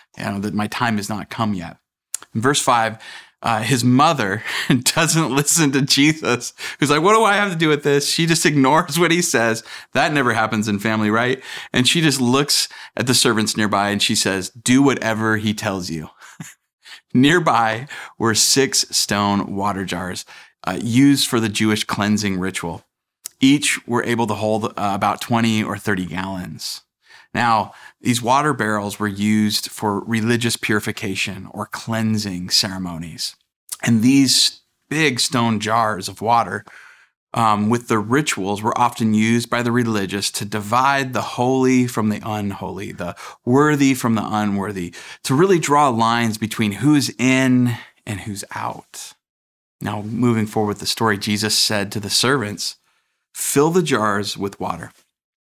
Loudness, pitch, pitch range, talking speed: -18 LUFS, 110 Hz, 105-130 Hz, 160 wpm